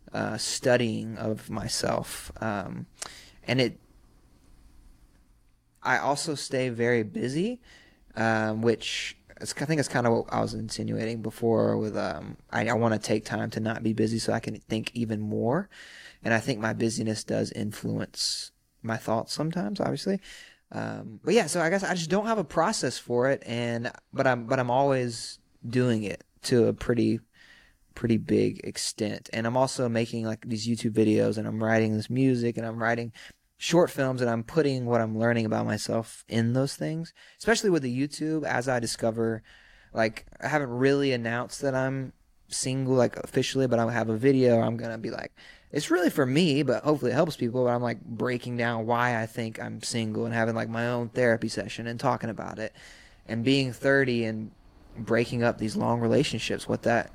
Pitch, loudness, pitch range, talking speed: 115 Hz, -27 LUFS, 110-130 Hz, 185 wpm